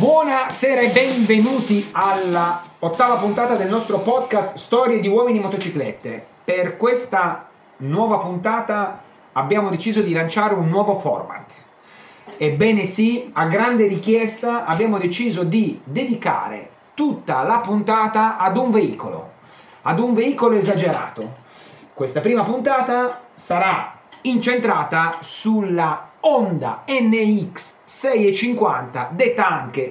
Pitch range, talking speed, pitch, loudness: 185-240 Hz, 105 wpm, 215 Hz, -19 LUFS